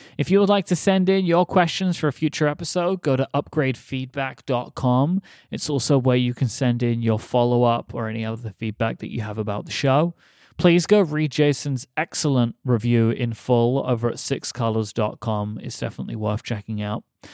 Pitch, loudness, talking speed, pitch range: 130 Hz, -22 LUFS, 180 wpm, 115-155 Hz